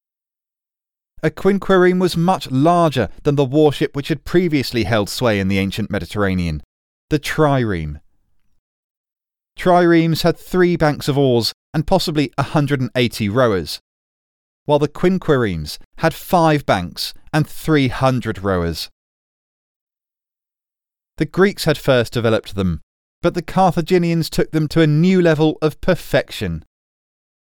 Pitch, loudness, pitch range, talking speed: 145 Hz, -17 LUFS, 100-165 Hz, 120 wpm